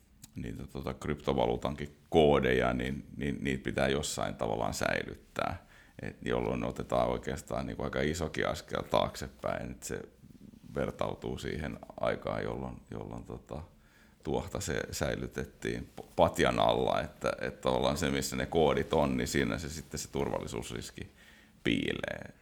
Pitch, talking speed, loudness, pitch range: 65 Hz, 135 wpm, -33 LUFS, 65-75 Hz